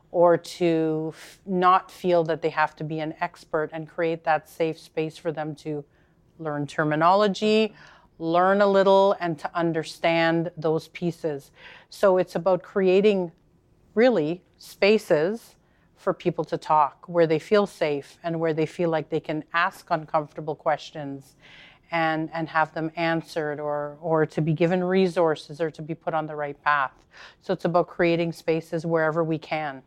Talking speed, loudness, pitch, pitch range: 165 wpm, -24 LUFS, 165 Hz, 155-175 Hz